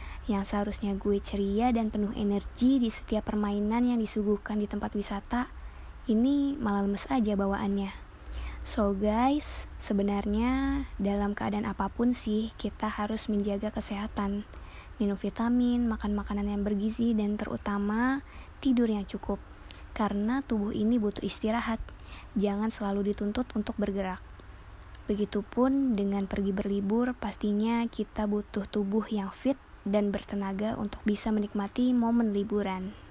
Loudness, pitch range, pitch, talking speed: -30 LUFS, 205-230 Hz, 210 Hz, 125 wpm